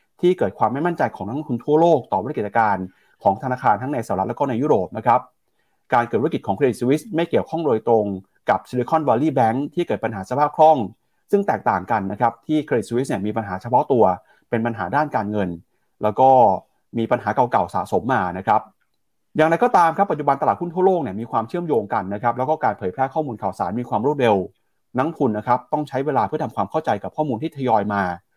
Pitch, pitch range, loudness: 130 Hz, 110-155 Hz, -21 LUFS